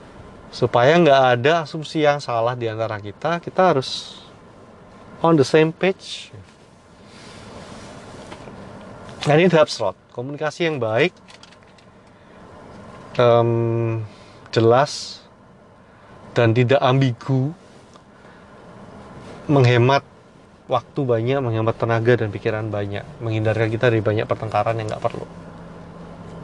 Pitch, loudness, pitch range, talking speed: 120 Hz, -19 LUFS, 115-145 Hz, 100 wpm